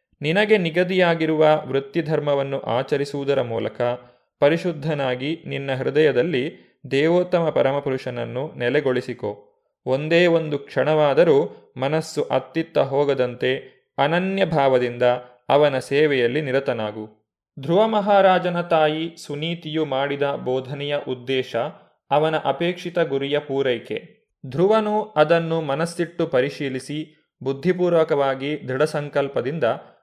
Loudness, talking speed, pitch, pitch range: -21 LUFS, 80 wpm, 145 Hz, 135-165 Hz